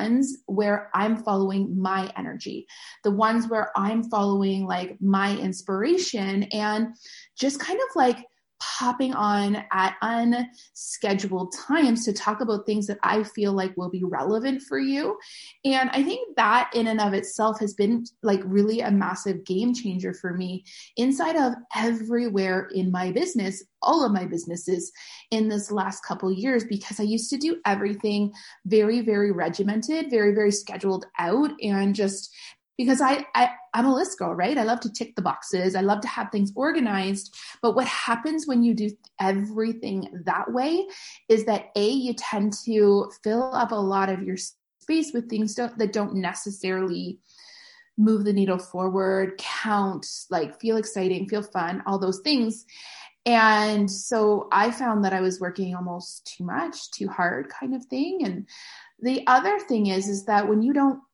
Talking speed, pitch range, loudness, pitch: 170 wpm, 195-245 Hz, -25 LUFS, 215 Hz